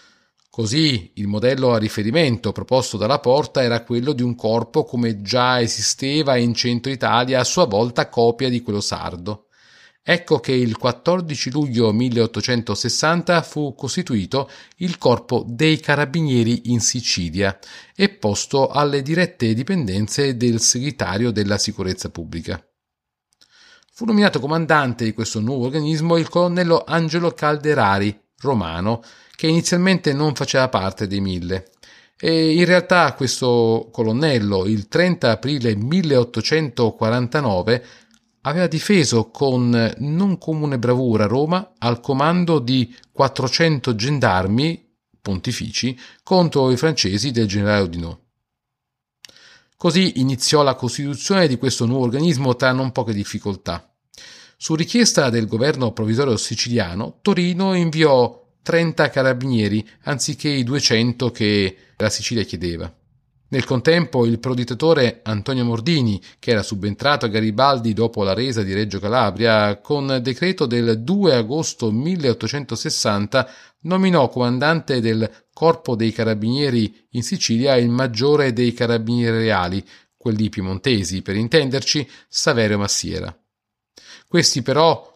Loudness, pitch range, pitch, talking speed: -19 LUFS, 110-150 Hz, 125 Hz, 120 wpm